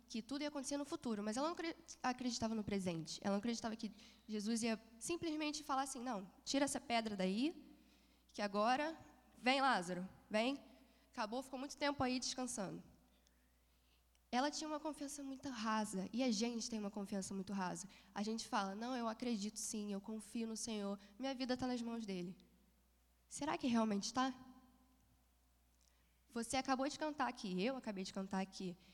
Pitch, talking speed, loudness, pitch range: 230 Hz, 170 wpm, -42 LUFS, 195-260 Hz